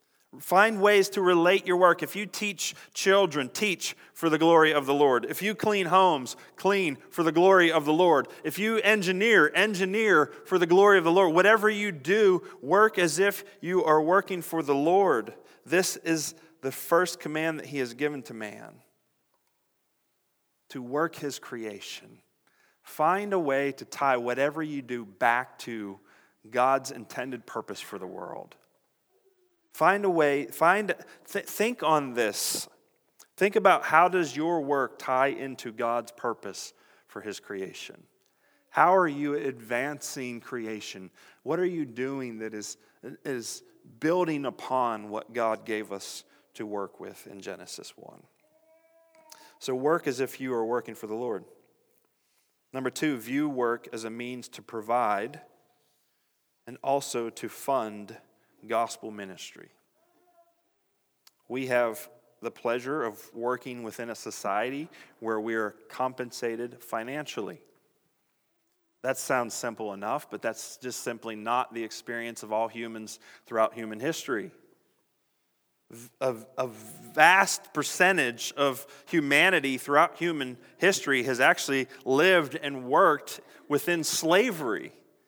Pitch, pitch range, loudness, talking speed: 145 Hz, 120-185 Hz, -26 LUFS, 140 wpm